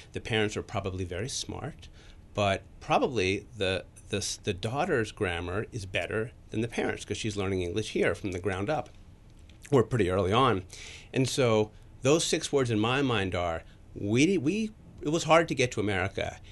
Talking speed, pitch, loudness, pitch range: 180 wpm, 105 Hz, -29 LUFS, 95-120 Hz